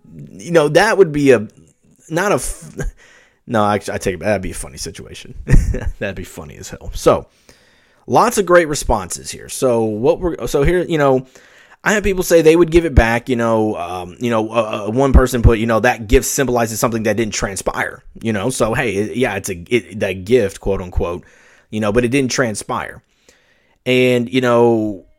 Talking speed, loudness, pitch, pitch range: 200 wpm, -16 LUFS, 120 Hz, 105-130 Hz